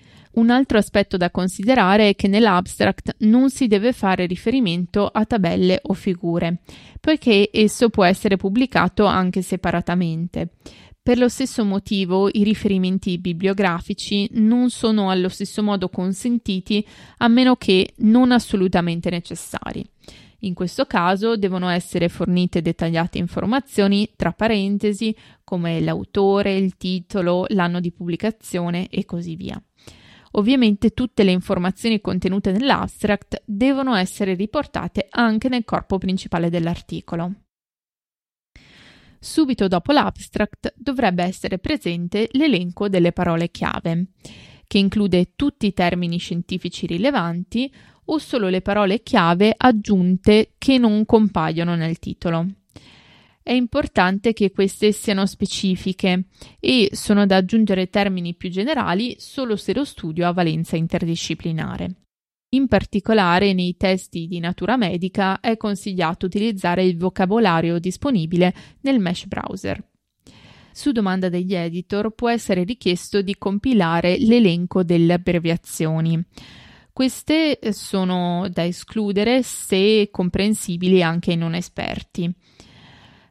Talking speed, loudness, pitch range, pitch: 115 wpm, -20 LUFS, 180-220 Hz, 195 Hz